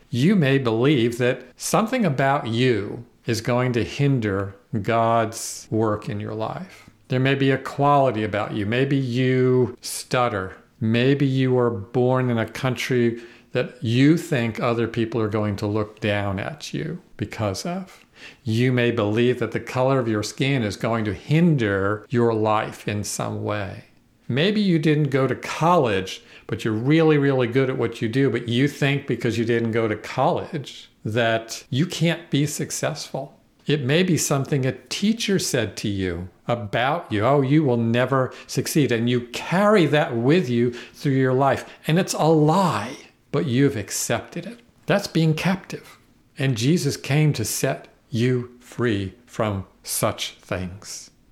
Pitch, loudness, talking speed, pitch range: 125 Hz, -22 LUFS, 165 wpm, 115-145 Hz